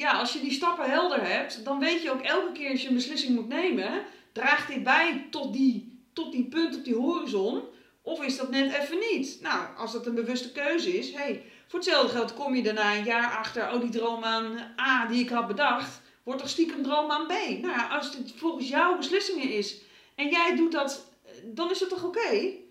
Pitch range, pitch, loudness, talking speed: 245-325 Hz, 280 Hz, -28 LUFS, 230 wpm